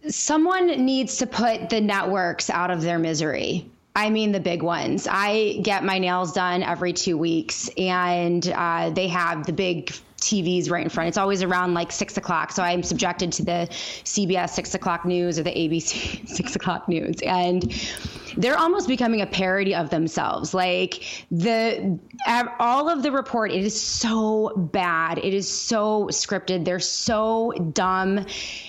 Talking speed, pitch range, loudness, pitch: 165 wpm, 175-215 Hz, -23 LUFS, 185 Hz